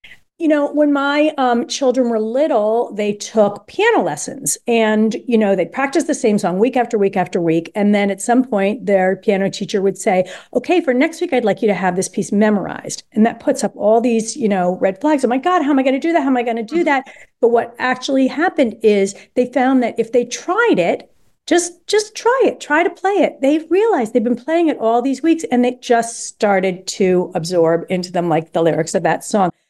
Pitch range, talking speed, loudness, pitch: 200-285 Hz, 235 wpm, -16 LUFS, 235 Hz